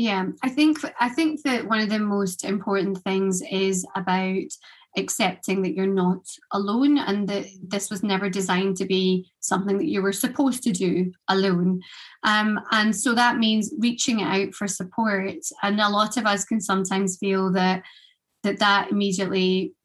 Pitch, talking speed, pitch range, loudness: 200 Hz, 170 wpm, 190-220 Hz, -23 LUFS